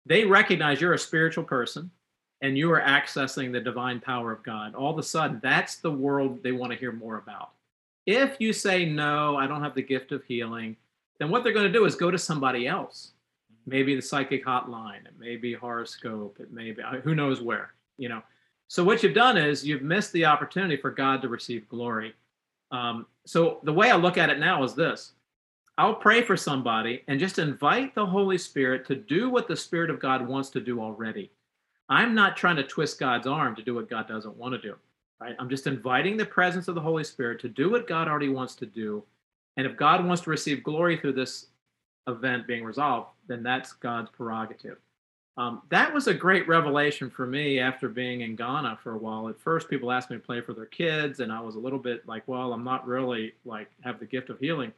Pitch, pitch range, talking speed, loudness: 135 Hz, 120-165 Hz, 220 wpm, -26 LUFS